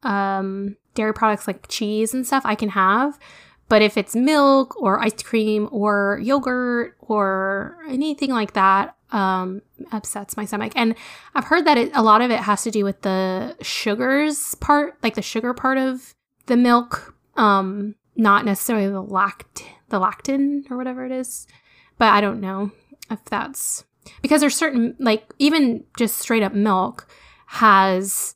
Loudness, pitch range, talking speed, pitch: -20 LUFS, 205-260 Hz, 165 wpm, 225 Hz